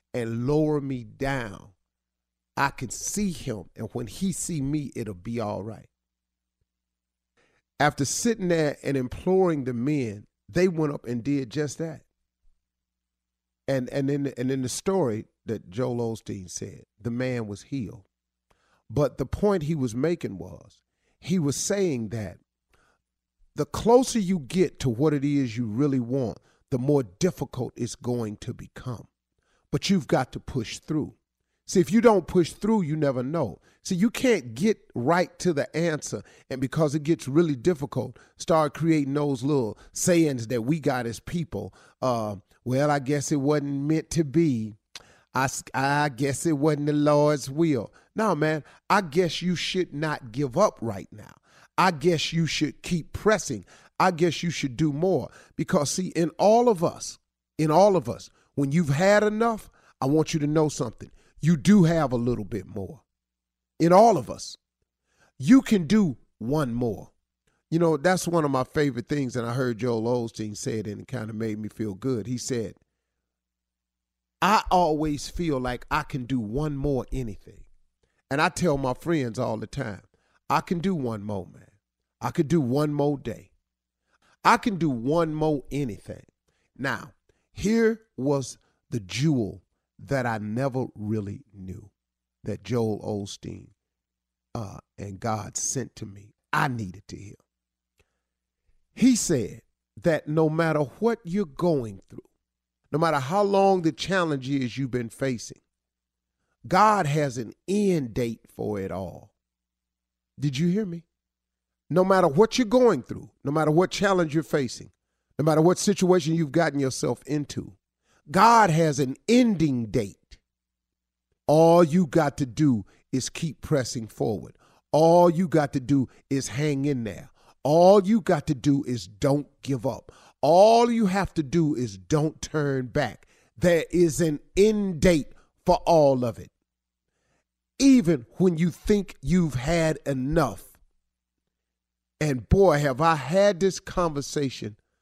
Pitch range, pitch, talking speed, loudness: 110-165 Hz, 140 Hz, 160 wpm, -25 LUFS